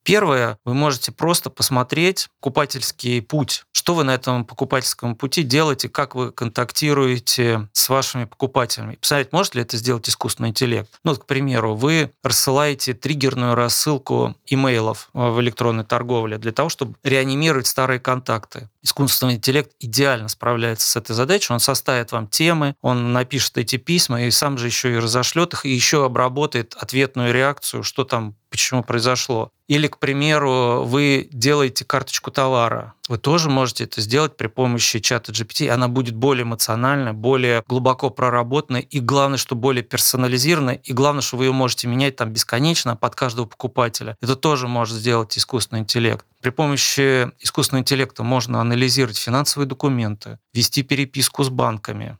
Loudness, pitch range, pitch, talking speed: -19 LUFS, 120-140 Hz, 130 Hz, 155 wpm